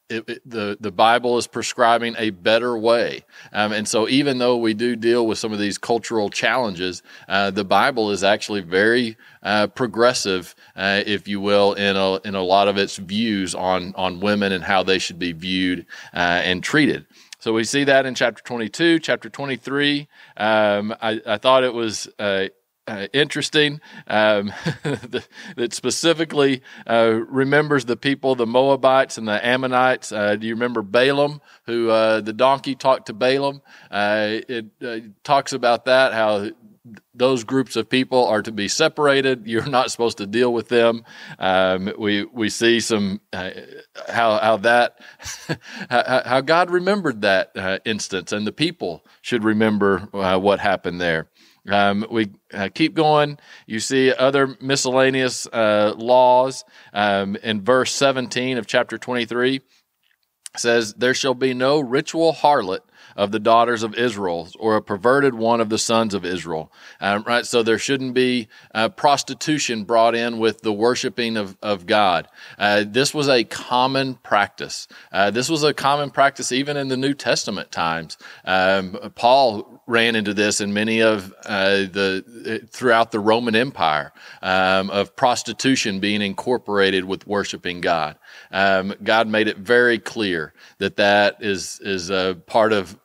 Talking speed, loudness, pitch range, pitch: 165 wpm, -20 LUFS, 100-130 Hz, 115 Hz